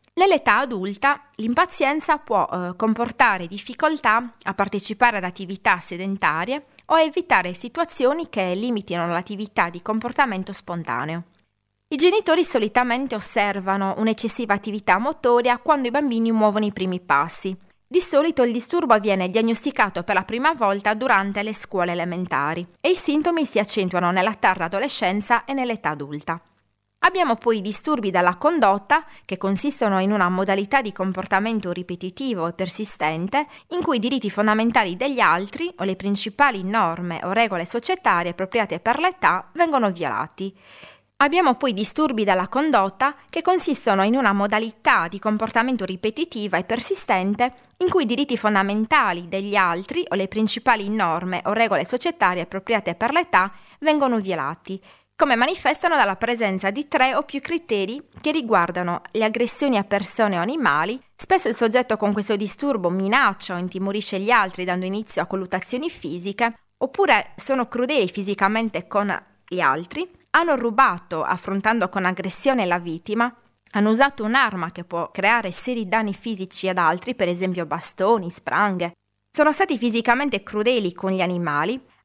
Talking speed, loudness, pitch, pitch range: 145 wpm, -21 LUFS, 215 Hz, 190-260 Hz